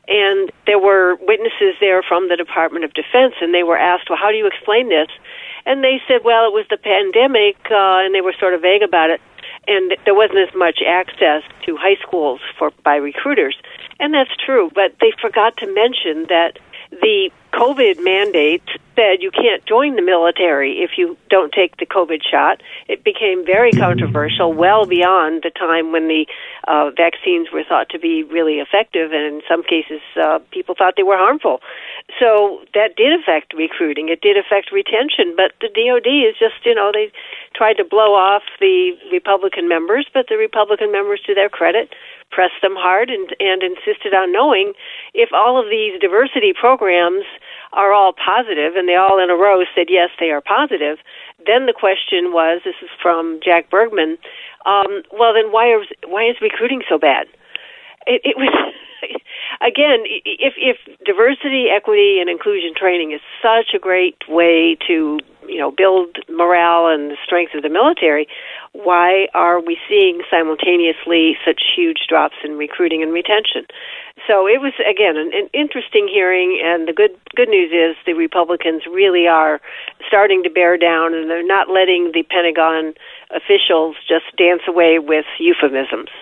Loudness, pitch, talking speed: -15 LUFS, 200 Hz, 175 wpm